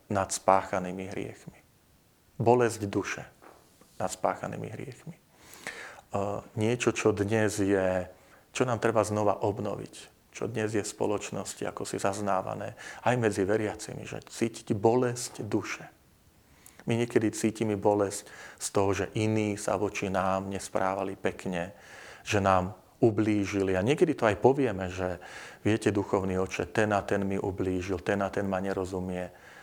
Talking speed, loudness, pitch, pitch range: 135 wpm, -29 LUFS, 100 Hz, 95-110 Hz